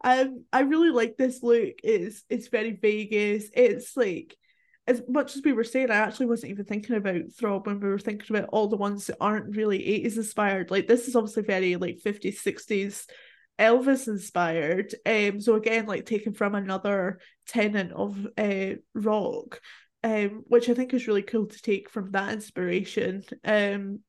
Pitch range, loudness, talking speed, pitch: 200-235 Hz, -26 LUFS, 180 wpm, 215 Hz